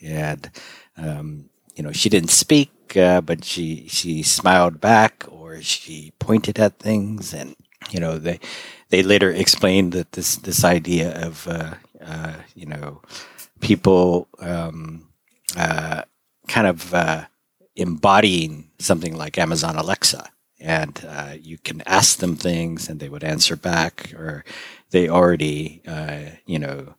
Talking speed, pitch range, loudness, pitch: 140 wpm, 80-90 Hz, -19 LUFS, 85 Hz